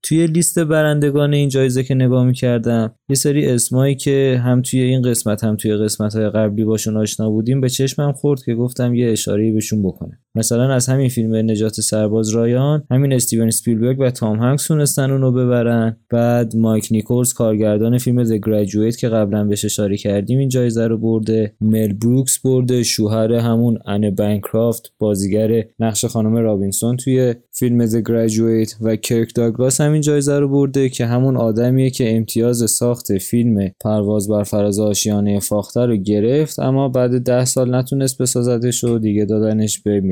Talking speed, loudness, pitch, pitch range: 165 wpm, -16 LUFS, 115 Hz, 110-130 Hz